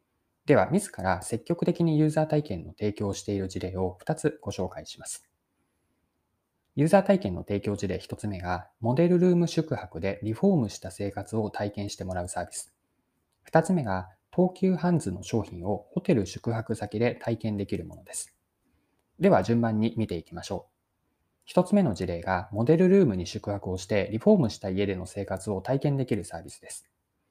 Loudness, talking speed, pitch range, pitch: -27 LUFS, 350 characters per minute, 95-140 Hz, 105 Hz